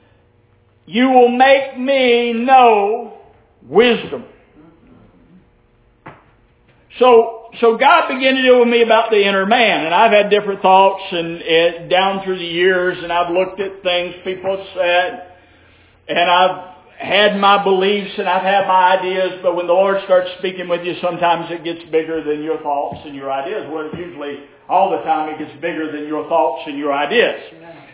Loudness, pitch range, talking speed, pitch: -15 LUFS, 160-200 Hz, 170 wpm, 180 Hz